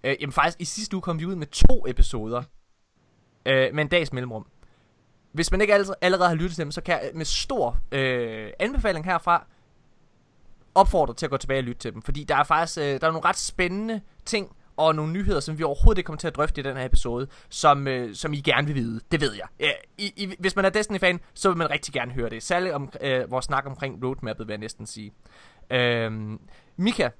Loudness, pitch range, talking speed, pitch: -25 LUFS, 125-175 Hz, 235 wpm, 145 Hz